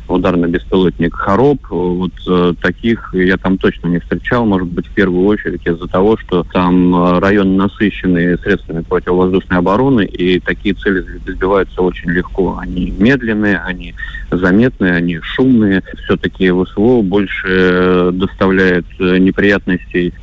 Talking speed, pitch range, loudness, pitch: 135 wpm, 90-95 Hz, -13 LUFS, 90 Hz